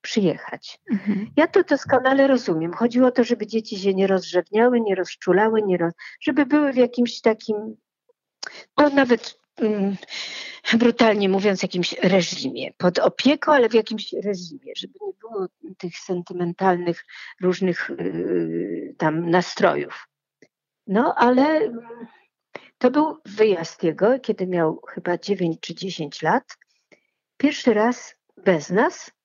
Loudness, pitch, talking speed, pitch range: -21 LUFS, 215 Hz, 125 wpm, 180-255 Hz